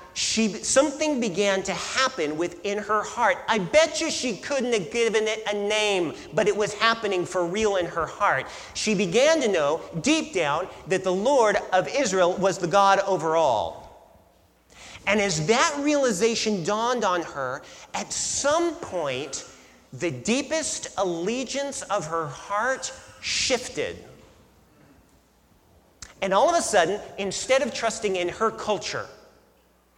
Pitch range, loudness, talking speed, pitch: 185-255 Hz, -24 LUFS, 140 wpm, 210 Hz